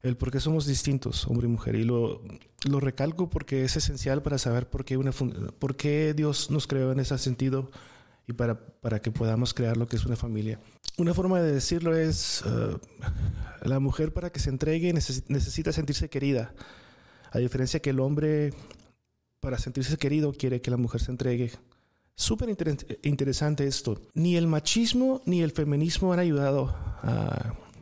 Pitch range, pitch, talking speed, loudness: 120-150 Hz, 135 Hz, 175 wpm, -28 LUFS